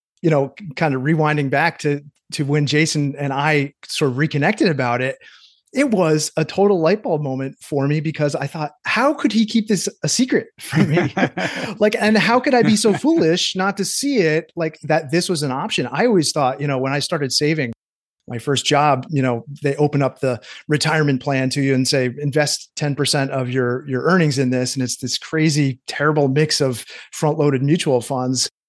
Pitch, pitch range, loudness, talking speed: 150 Hz, 135-165 Hz, -19 LUFS, 205 wpm